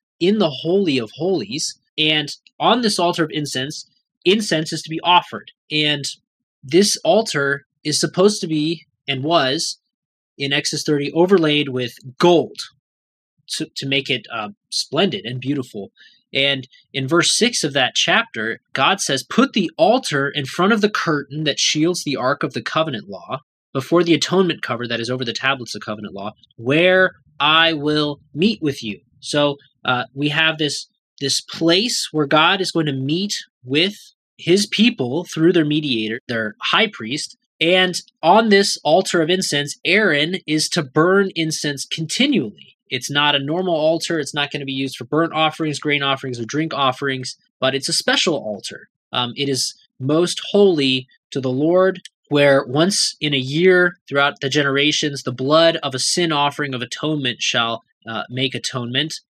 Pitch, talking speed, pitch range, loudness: 150 Hz, 170 wpm, 135-175 Hz, -18 LUFS